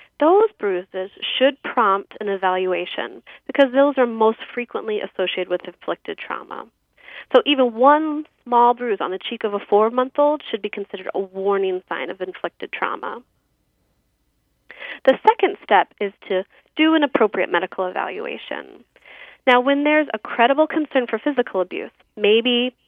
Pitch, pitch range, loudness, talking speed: 235 Hz, 195-275 Hz, -20 LUFS, 150 wpm